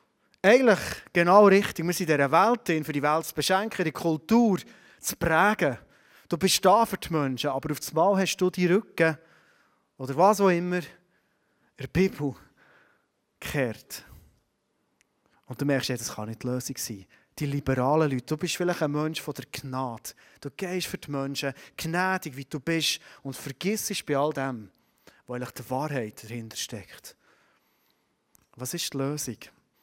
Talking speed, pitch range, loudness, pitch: 165 wpm, 135-180 Hz, -26 LUFS, 150 Hz